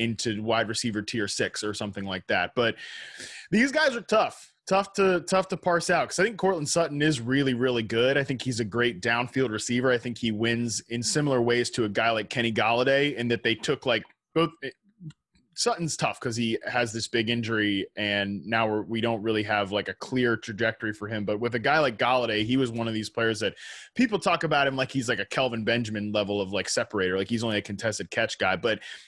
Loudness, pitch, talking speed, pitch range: -26 LUFS, 120 Hz, 230 wpm, 110-135 Hz